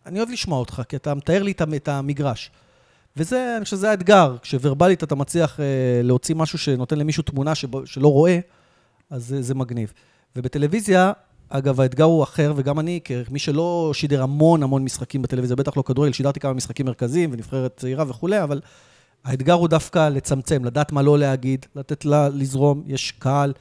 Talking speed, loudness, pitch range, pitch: 170 wpm, -21 LUFS, 135-160 Hz, 145 Hz